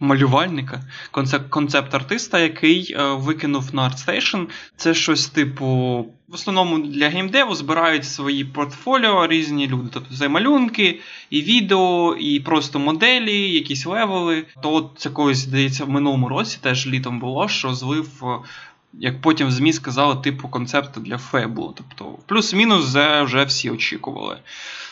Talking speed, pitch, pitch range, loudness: 135 wpm, 145 Hz, 135-170 Hz, -19 LUFS